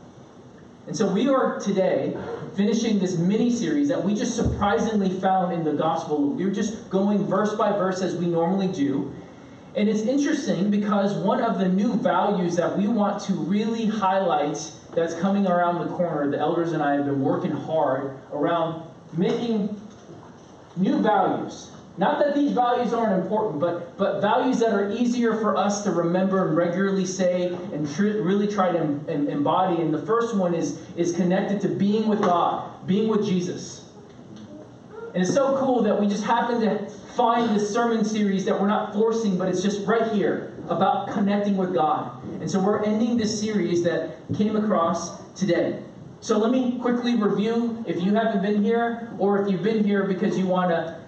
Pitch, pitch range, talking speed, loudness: 200 Hz, 175-220 Hz, 180 wpm, -23 LUFS